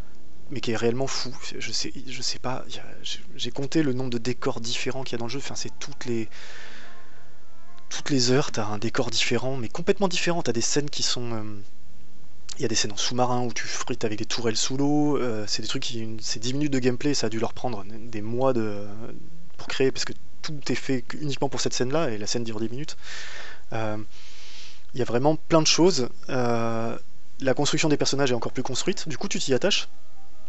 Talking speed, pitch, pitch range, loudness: 230 wpm, 120 Hz, 110-140 Hz, -27 LUFS